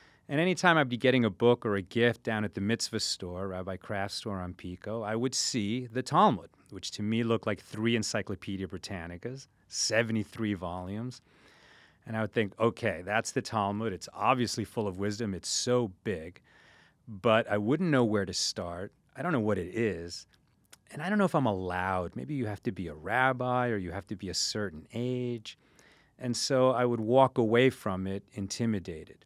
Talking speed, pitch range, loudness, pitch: 195 wpm, 95-120 Hz, -30 LUFS, 110 Hz